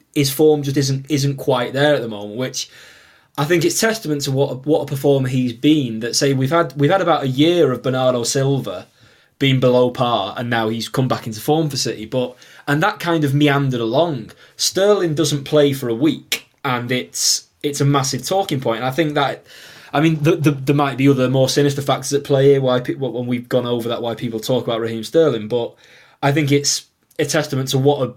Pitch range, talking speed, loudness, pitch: 125-150 Hz, 225 wpm, -18 LUFS, 140 Hz